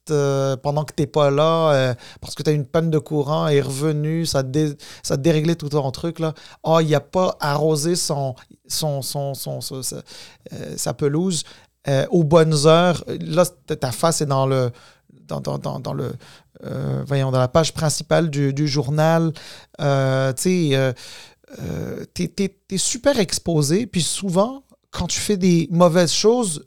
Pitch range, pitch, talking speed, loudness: 140-170 Hz, 155 Hz, 175 wpm, -20 LUFS